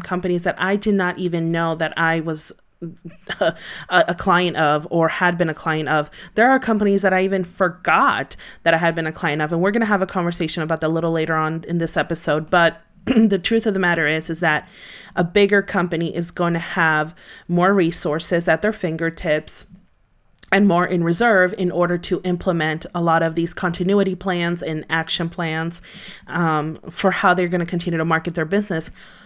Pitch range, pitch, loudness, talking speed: 165-185 Hz, 175 Hz, -19 LUFS, 205 wpm